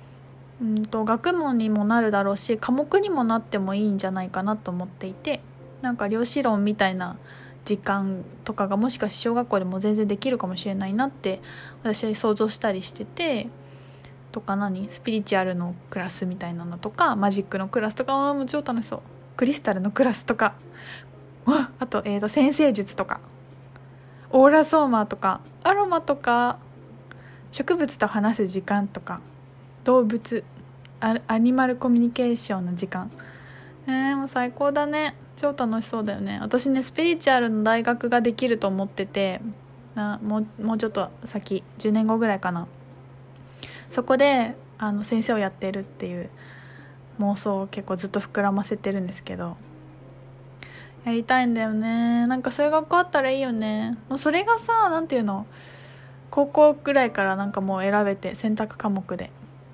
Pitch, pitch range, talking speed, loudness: 215 Hz, 190-250 Hz, 335 characters per minute, -24 LUFS